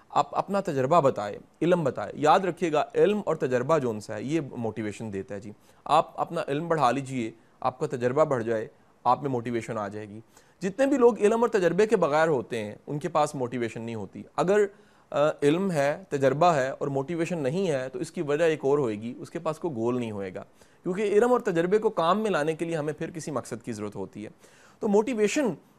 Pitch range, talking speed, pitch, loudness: 120-175 Hz, 225 wpm, 145 Hz, -26 LUFS